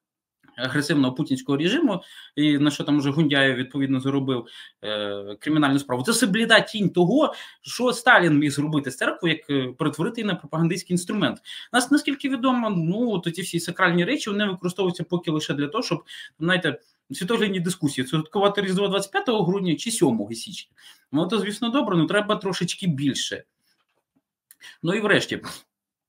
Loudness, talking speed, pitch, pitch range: -23 LUFS, 150 wpm, 170 Hz, 145-205 Hz